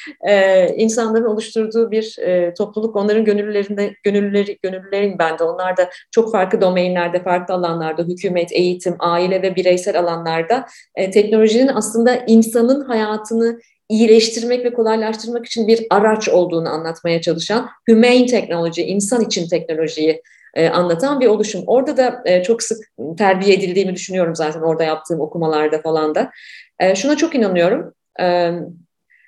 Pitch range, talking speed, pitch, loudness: 175-225 Hz, 135 wpm, 200 Hz, -16 LUFS